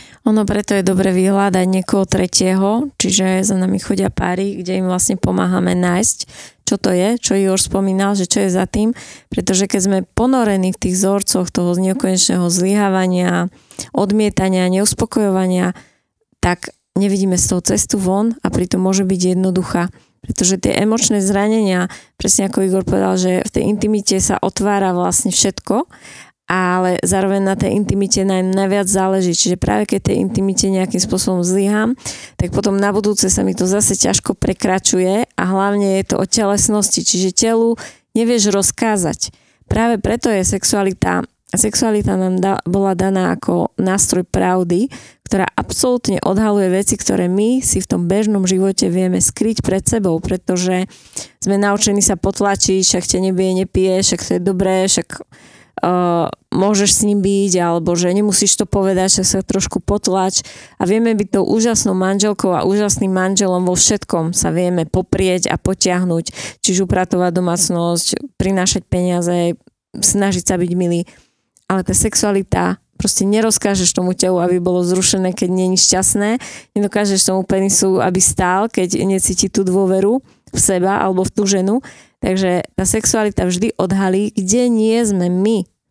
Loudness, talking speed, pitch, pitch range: -15 LUFS, 155 wpm, 190 Hz, 185-205 Hz